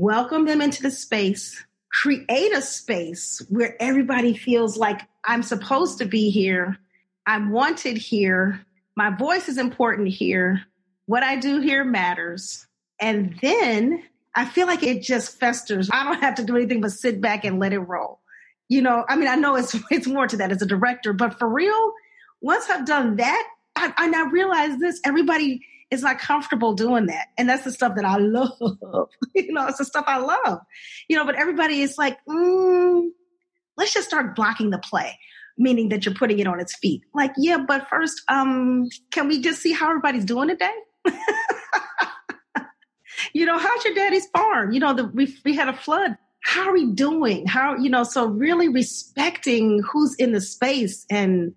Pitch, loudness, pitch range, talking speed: 260 Hz, -21 LUFS, 220-305 Hz, 185 wpm